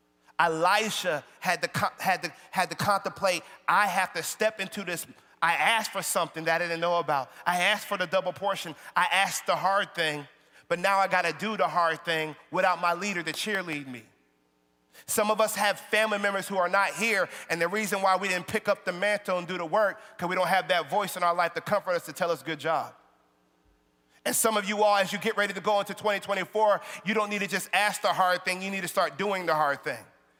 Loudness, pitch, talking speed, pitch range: -27 LUFS, 185 Hz, 235 wpm, 170-205 Hz